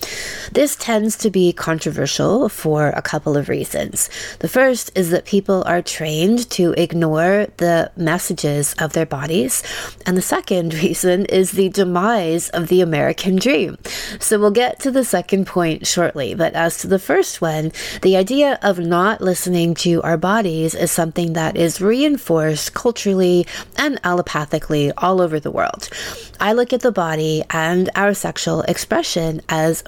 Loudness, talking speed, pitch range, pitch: -18 LUFS, 160 wpm, 165-205 Hz, 180 Hz